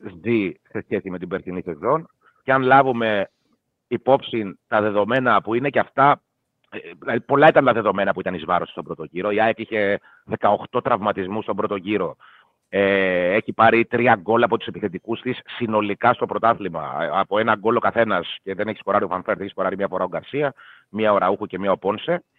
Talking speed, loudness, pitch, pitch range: 195 wpm, -21 LUFS, 105 Hz, 95-115 Hz